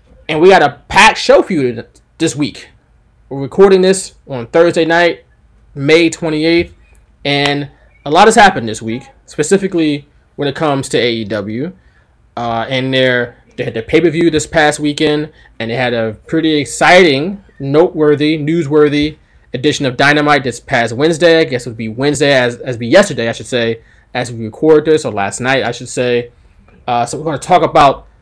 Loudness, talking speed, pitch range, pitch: -12 LUFS, 180 wpm, 120-155 Hz, 140 Hz